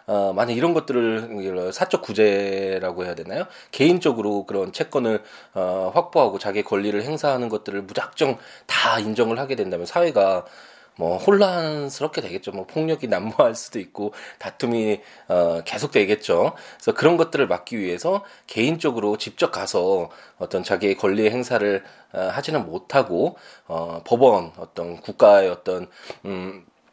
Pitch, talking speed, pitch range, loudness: 105 Hz, 310 characters per minute, 95-120 Hz, -22 LUFS